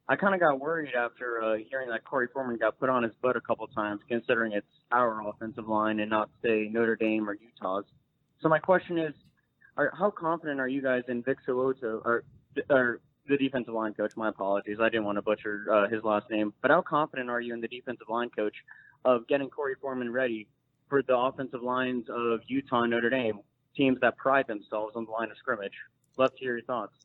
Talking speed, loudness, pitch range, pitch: 220 wpm, -29 LUFS, 110-135 Hz, 120 Hz